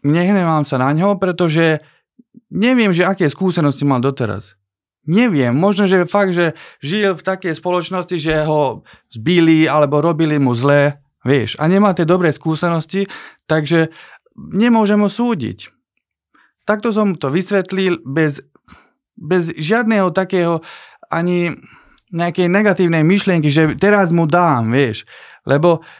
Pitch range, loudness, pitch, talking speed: 150-195 Hz, -15 LUFS, 170 Hz, 125 wpm